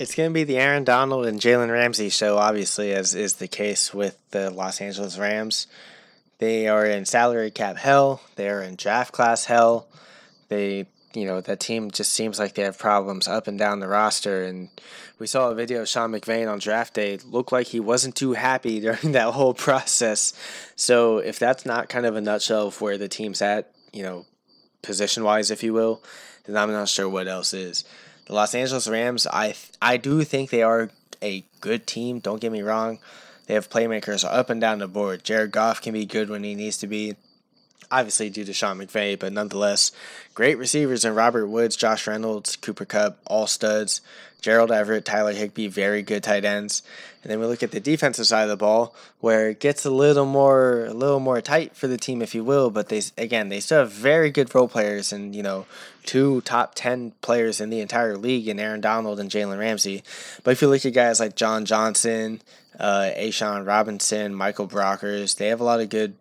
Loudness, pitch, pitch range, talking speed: -22 LUFS, 110 Hz, 105-120 Hz, 210 wpm